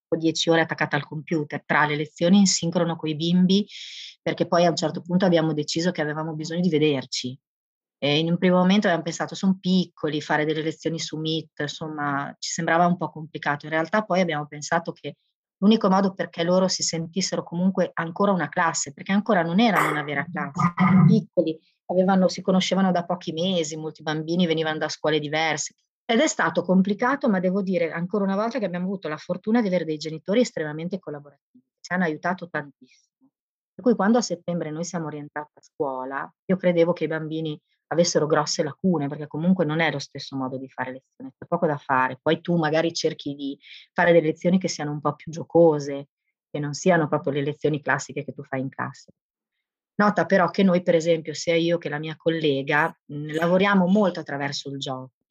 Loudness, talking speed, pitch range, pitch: -23 LUFS, 200 wpm, 150-180 Hz, 165 Hz